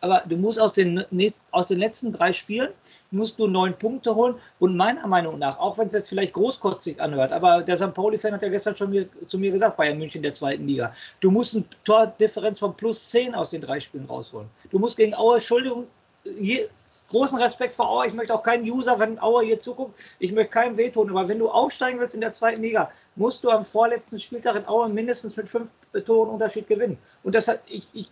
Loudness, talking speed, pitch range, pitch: -23 LUFS, 230 wpm, 195-235 Hz, 220 Hz